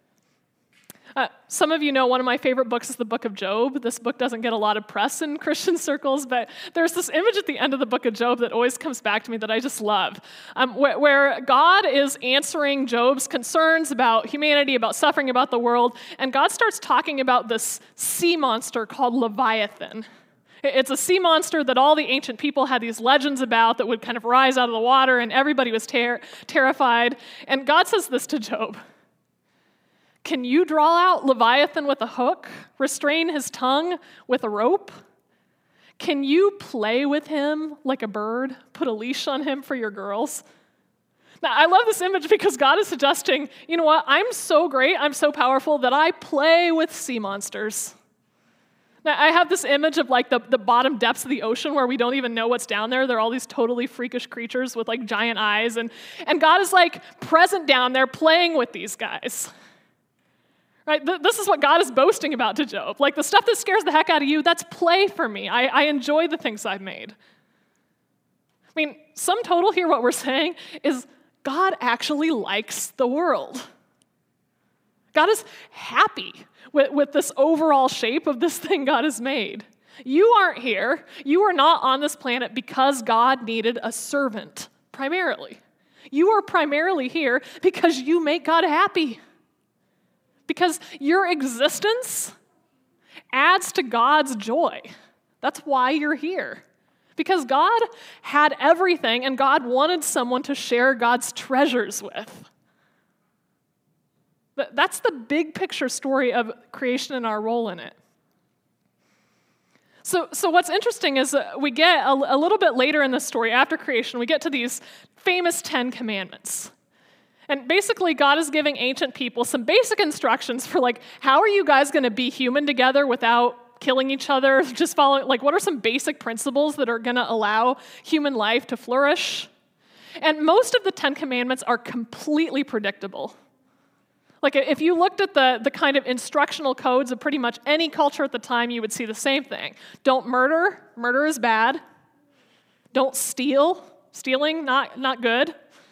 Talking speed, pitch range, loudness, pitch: 180 wpm, 245-315 Hz, -21 LUFS, 275 Hz